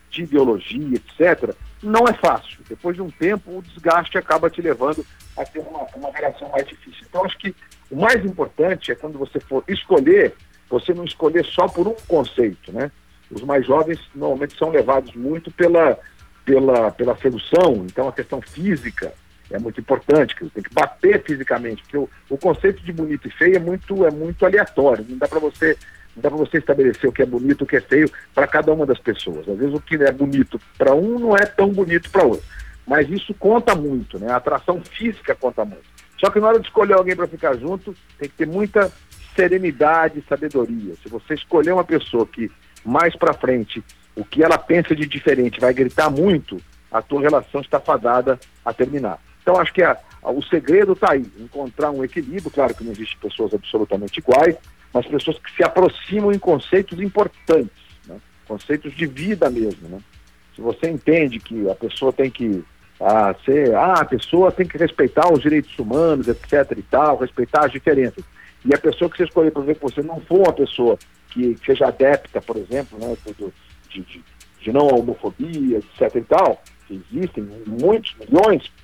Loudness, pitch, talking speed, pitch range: -19 LUFS, 150 Hz, 195 wpm, 125-180 Hz